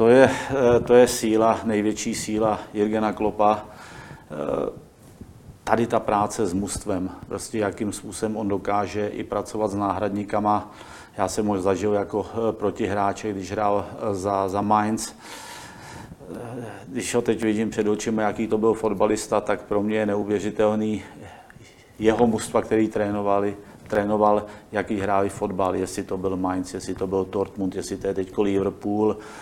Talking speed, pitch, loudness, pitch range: 145 wpm, 105 Hz, -24 LUFS, 100-110 Hz